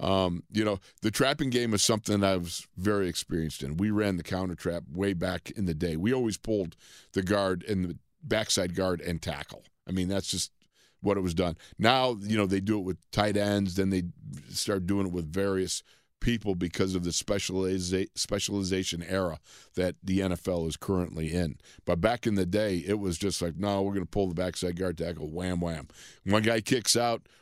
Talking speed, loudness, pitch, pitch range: 210 wpm, -29 LUFS, 95 Hz, 90-100 Hz